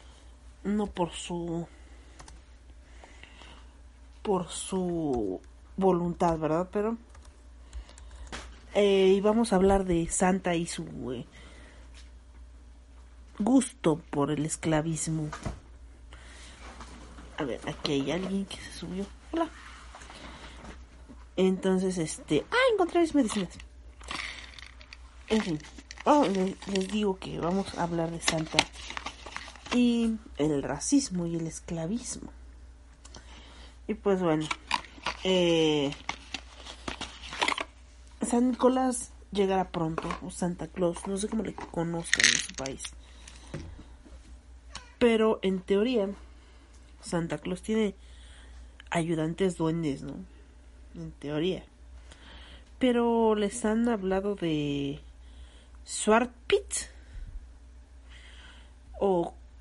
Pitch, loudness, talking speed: 155 Hz, -29 LUFS, 95 wpm